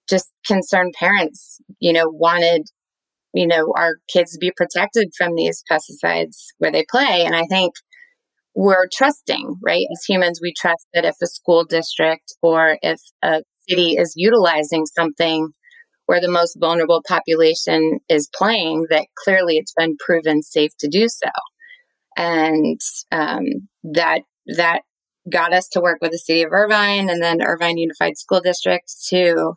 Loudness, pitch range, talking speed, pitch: -17 LUFS, 165-190 Hz, 155 wpm, 170 Hz